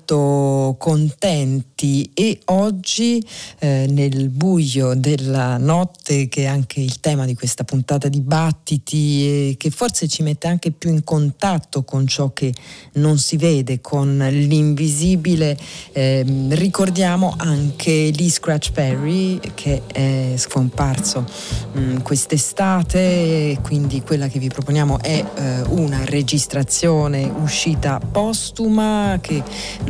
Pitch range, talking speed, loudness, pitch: 135-165 Hz, 115 wpm, -18 LUFS, 145 Hz